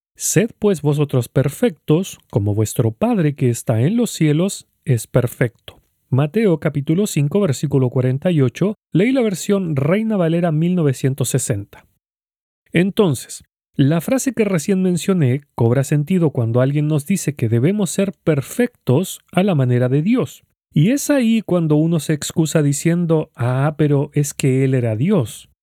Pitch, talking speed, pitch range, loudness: 155 Hz, 145 wpm, 135-190 Hz, -18 LUFS